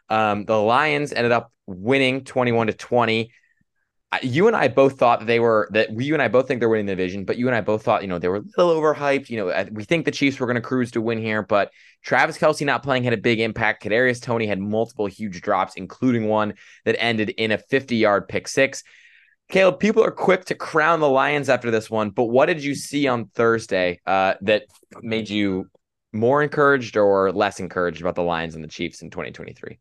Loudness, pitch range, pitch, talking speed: -21 LUFS, 105-135 Hz, 115 Hz, 230 wpm